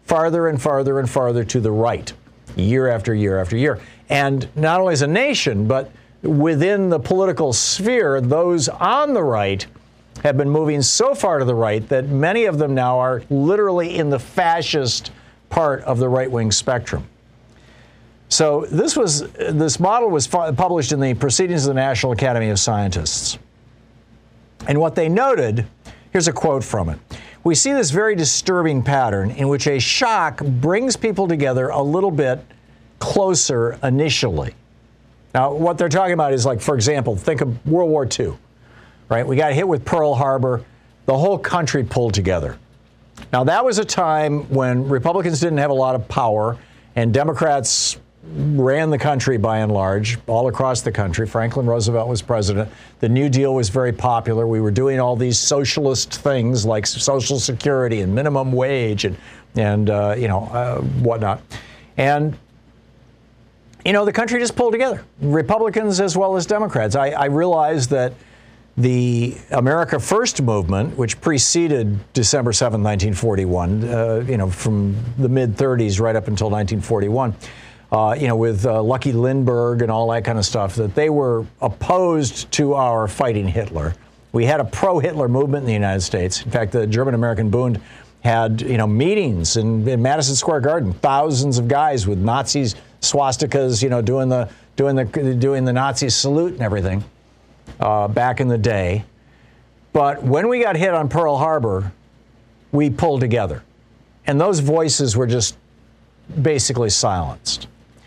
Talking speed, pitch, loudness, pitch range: 165 wpm, 125 Hz, -18 LUFS, 115-145 Hz